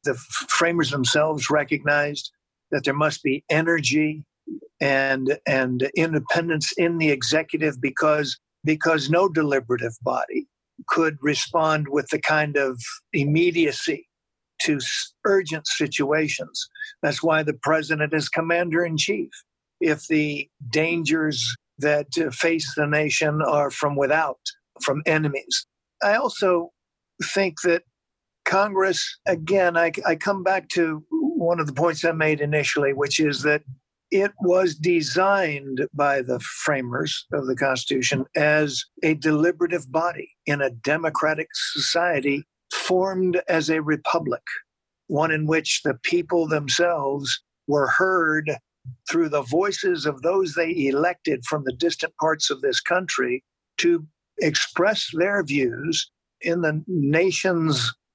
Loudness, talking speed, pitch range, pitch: -22 LUFS, 125 wpm, 145-175 Hz, 155 Hz